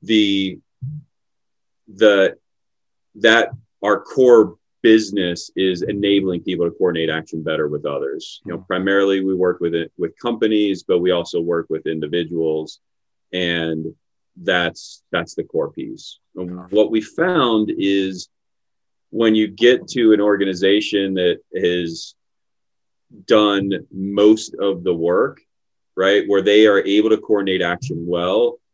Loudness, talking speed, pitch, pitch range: -18 LUFS, 130 wpm, 100 Hz, 90-110 Hz